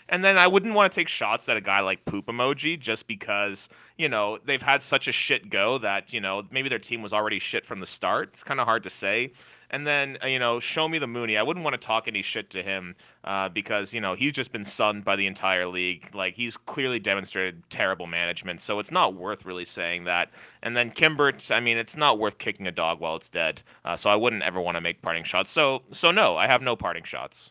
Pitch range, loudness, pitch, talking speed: 95-130 Hz, -25 LUFS, 110 Hz, 255 wpm